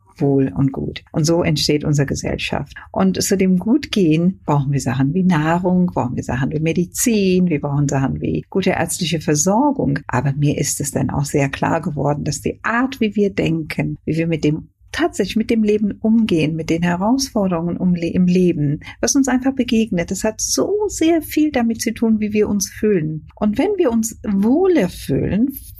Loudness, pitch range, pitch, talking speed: -18 LUFS, 150-220 Hz, 180 Hz, 190 wpm